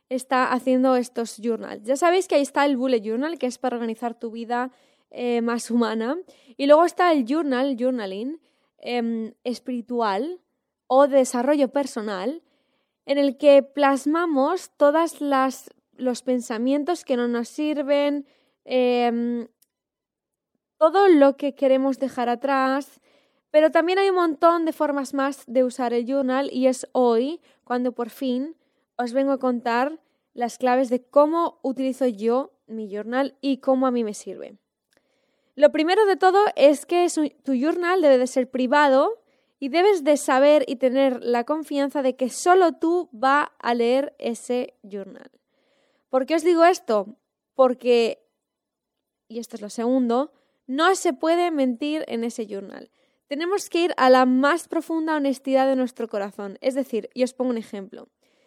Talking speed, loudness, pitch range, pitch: 160 wpm, -22 LUFS, 245-290 Hz, 270 Hz